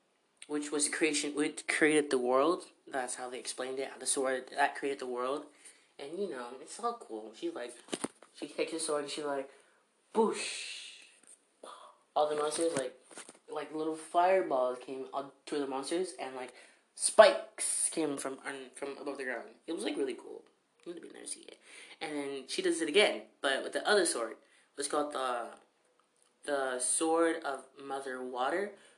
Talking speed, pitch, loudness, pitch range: 180 wpm, 145 Hz, -33 LUFS, 130-160 Hz